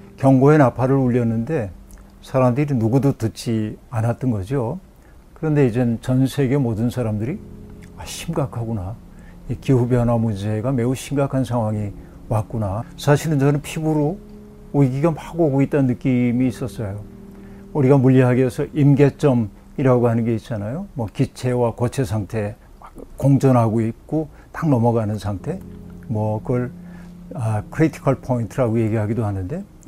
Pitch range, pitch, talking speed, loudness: 110-140 Hz, 125 Hz, 300 characters per minute, -20 LUFS